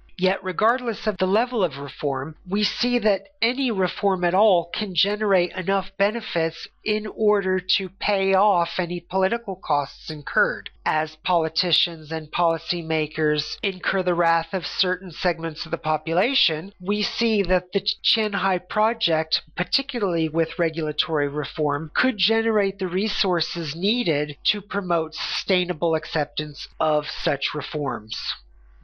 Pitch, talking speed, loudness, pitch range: 180 Hz, 130 wpm, -23 LUFS, 160-205 Hz